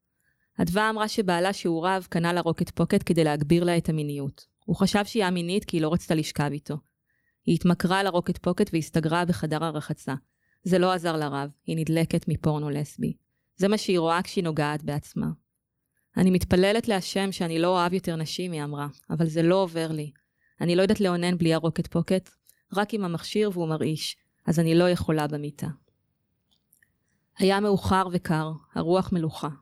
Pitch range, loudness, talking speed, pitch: 155-185 Hz, -26 LUFS, 170 wpm, 170 Hz